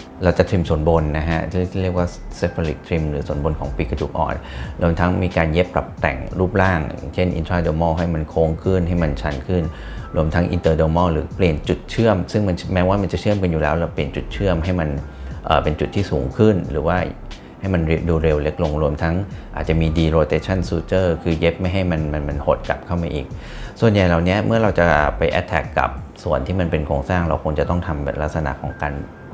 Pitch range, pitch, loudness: 75-90 Hz, 85 Hz, -20 LUFS